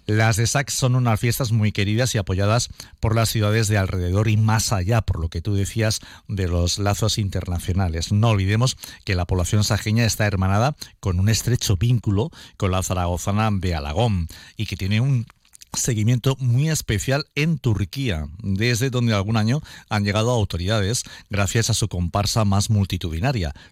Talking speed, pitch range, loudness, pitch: 170 wpm, 95-115 Hz, -22 LUFS, 110 Hz